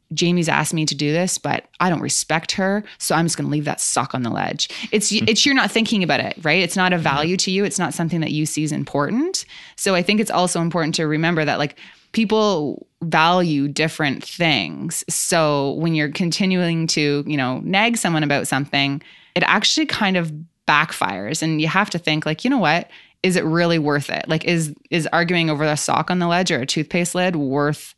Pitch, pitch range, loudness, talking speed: 165 Hz, 150-185 Hz, -19 LUFS, 220 wpm